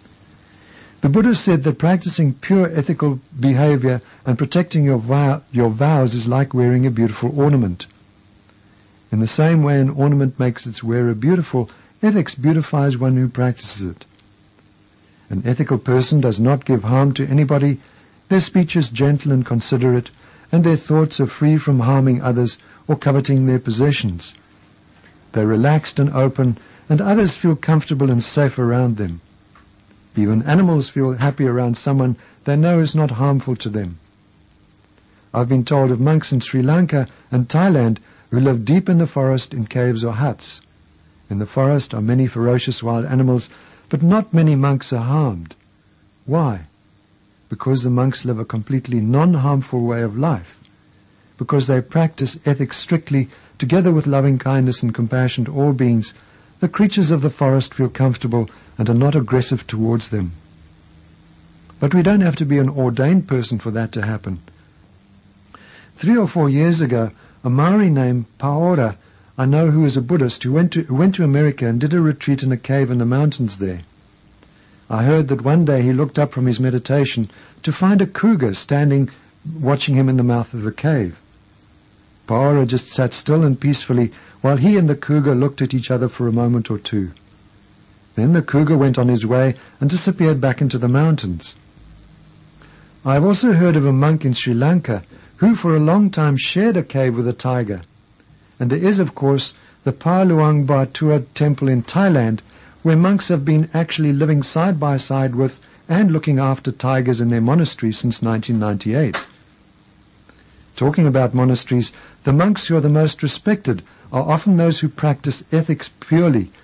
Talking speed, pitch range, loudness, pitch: 170 wpm, 115-150 Hz, -17 LUFS, 130 Hz